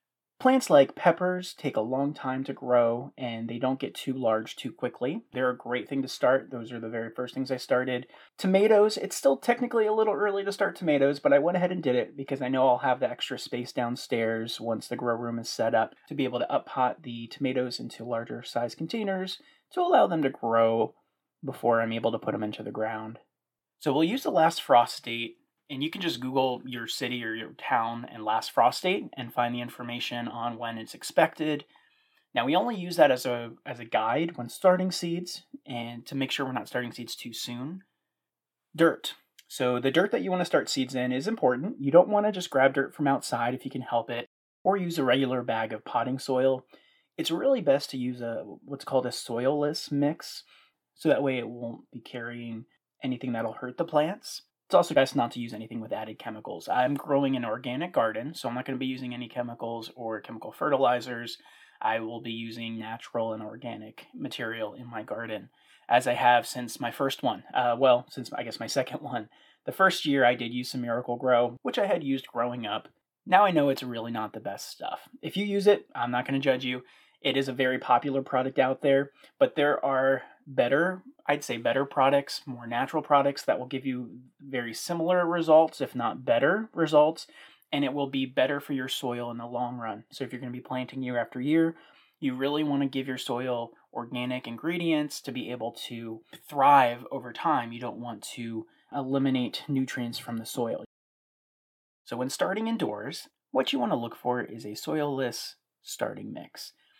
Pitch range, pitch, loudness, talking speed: 120-145 Hz, 130 Hz, -28 LUFS, 210 wpm